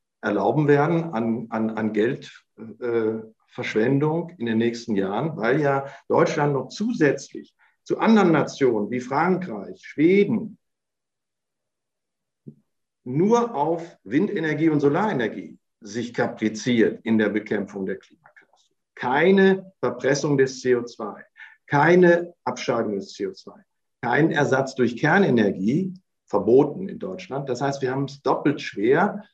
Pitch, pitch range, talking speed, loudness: 140 Hz, 120-175 Hz, 115 wpm, -22 LUFS